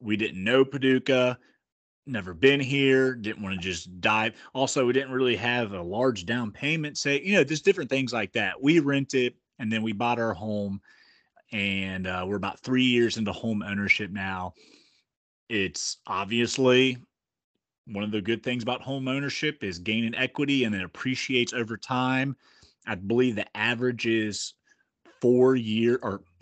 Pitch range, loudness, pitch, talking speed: 105-130 Hz, -26 LUFS, 120 Hz, 170 wpm